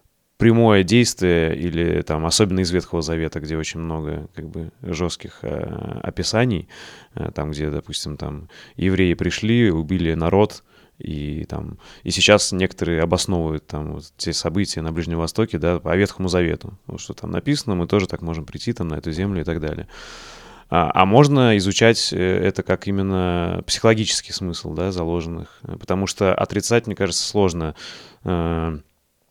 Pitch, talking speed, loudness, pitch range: 90 Hz, 155 wpm, -20 LUFS, 80-100 Hz